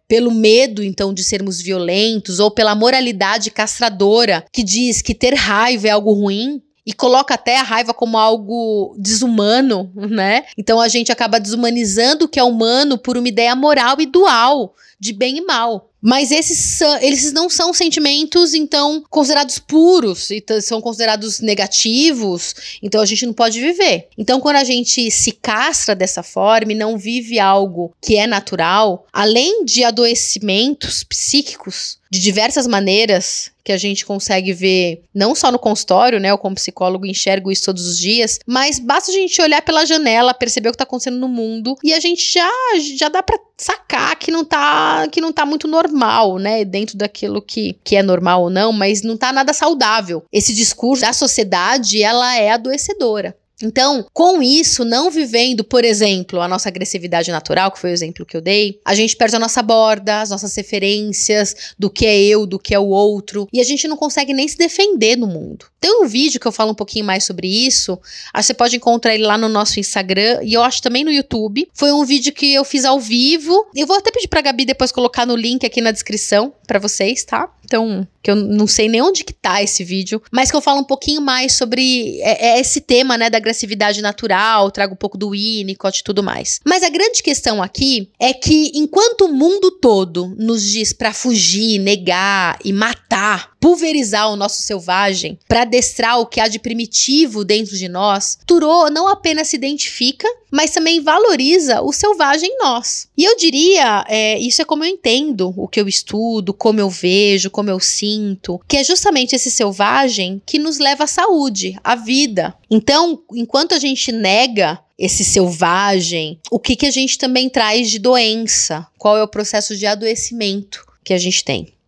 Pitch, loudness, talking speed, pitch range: 230 Hz, -14 LUFS, 190 wpm, 205-275 Hz